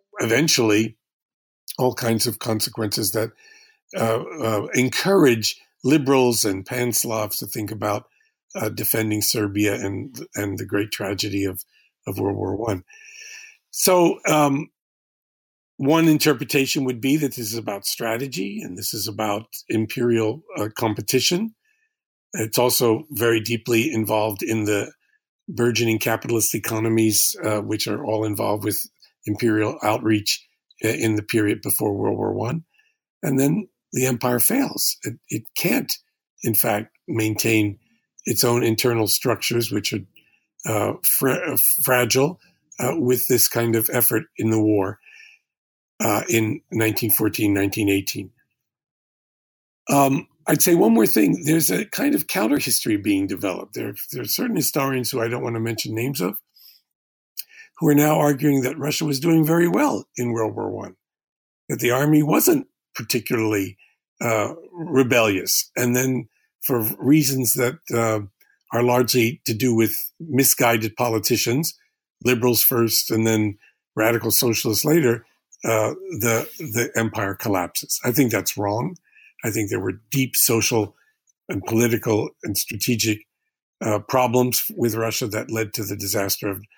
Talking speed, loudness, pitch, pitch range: 140 wpm, -21 LUFS, 115 Hz, 110-140 Hz